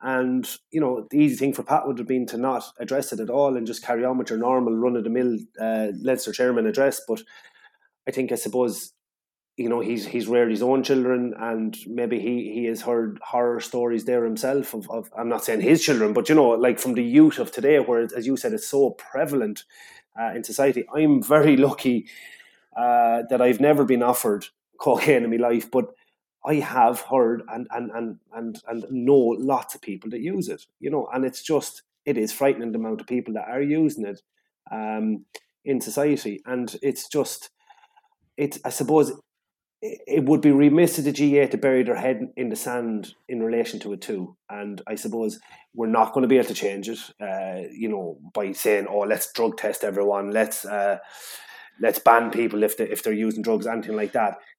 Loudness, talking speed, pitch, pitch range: -23 LUFS, 205 wpm, 125 Hz, 115-135 Hz